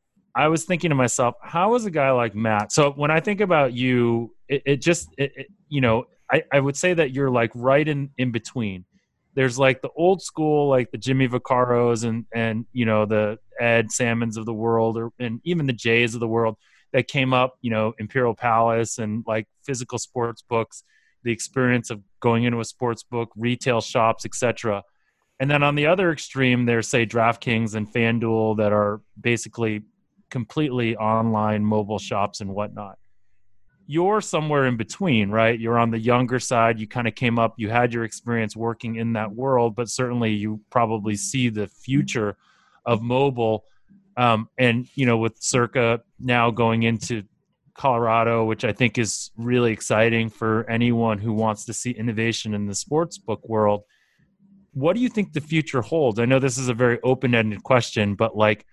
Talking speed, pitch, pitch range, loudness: 185 wpm, 120 Hz, 110-130 Hz, -22 LUFS